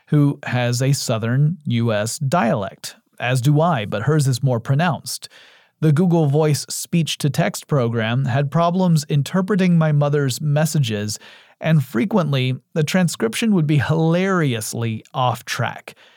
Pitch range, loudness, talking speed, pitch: 130-165 Hz, -19 LUFS, 135 wpm, 150 Hz